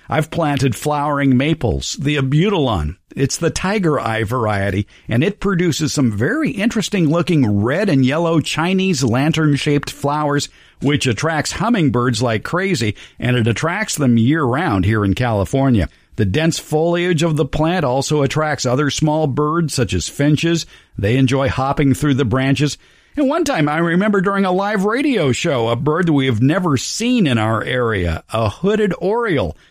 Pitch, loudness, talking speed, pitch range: 145 Hz, -17 LUFS, 160 wpm, 125-165 Hz